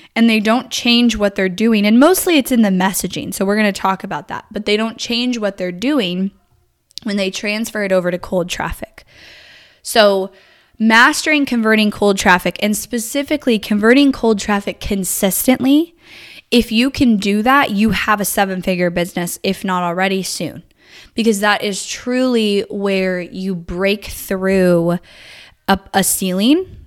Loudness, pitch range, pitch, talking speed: -15 LUFS, 190-235 Hz, 205 Hz, 160 wpm